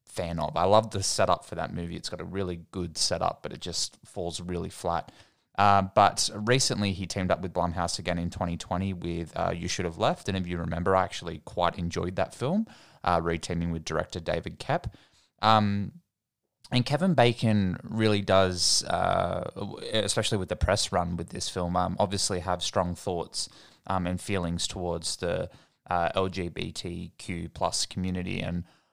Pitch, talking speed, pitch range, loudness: 90 Hz, 175 wpm, 85-100 Hz, -28 LUFS